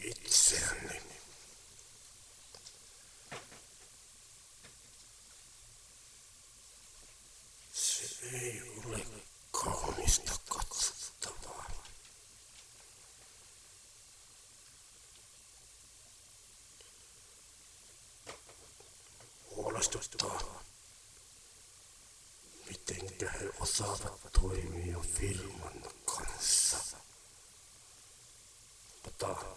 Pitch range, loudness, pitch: 95-115 Hz, -34 LUFS, 105 Hz